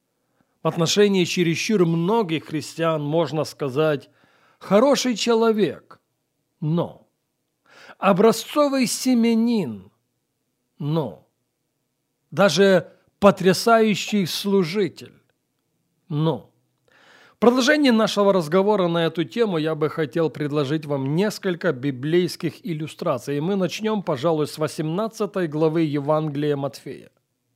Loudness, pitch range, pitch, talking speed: -21 LUFS, 155-205 Hz, 165 Hz, 90 wpm